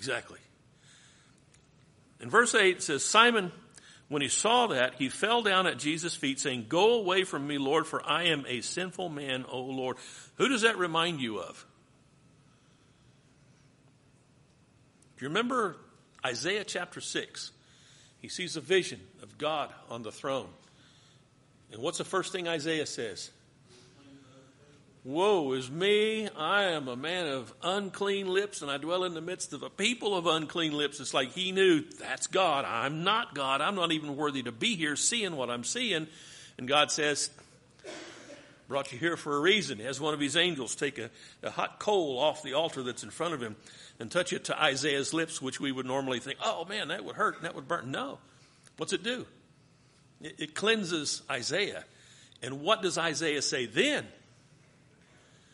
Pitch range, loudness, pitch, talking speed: 135-175 Hz, -30 LUFS, 145 Hz, 175 wpm